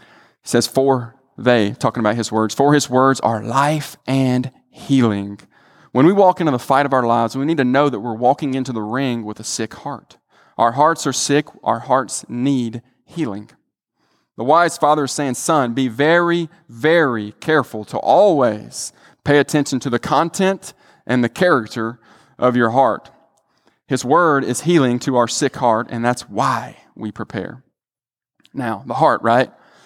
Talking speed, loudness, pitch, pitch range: 170 wpm, -17 LUFS, 130 Hz, 115-145 Hz